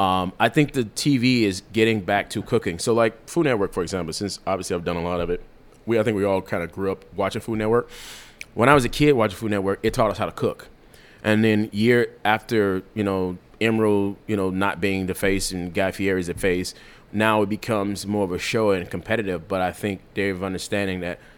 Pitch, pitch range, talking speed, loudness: 100 Hz, 95-110 Hz, 240 wpm, -23 LUFS